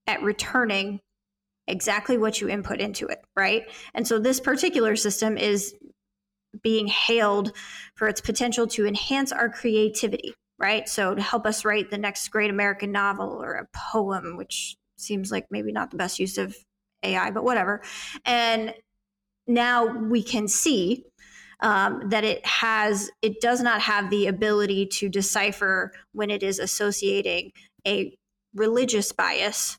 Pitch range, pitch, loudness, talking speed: 200-225 Hz, 210 Hz, -24 LUFS, 150 wpm